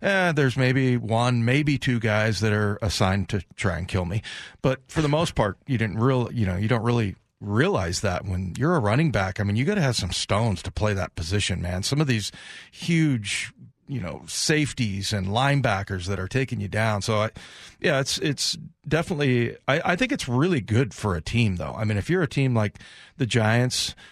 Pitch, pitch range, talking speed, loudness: 115 Hz, 100-135 Hz, 220 wpm, -24 LUFS